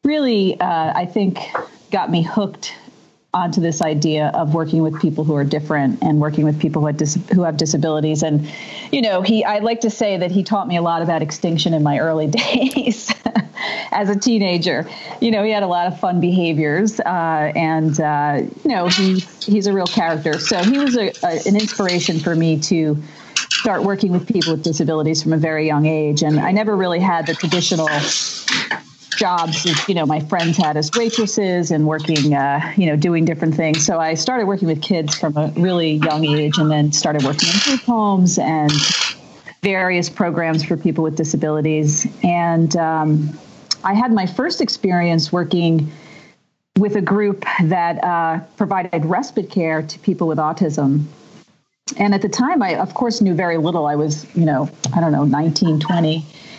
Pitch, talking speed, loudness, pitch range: 170 Hz, 190 wpm, -17 LUFS, 155-200 Hz